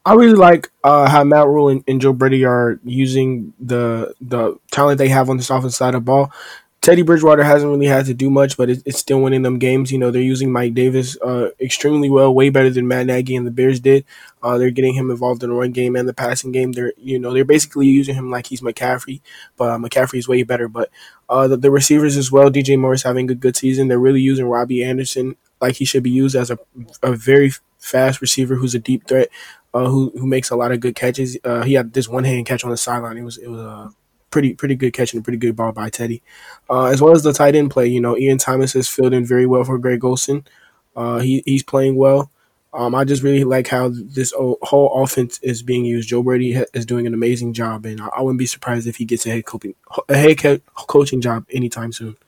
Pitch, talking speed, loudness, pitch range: 130 Hz, 250 wpm, -15 LUFS, 125-135 Hz